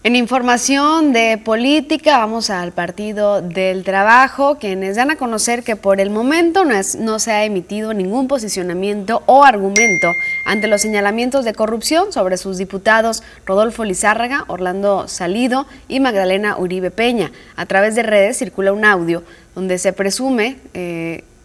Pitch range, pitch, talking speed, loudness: 195-245 Hz, 215 Hz, 155 wpm, -15 LUFS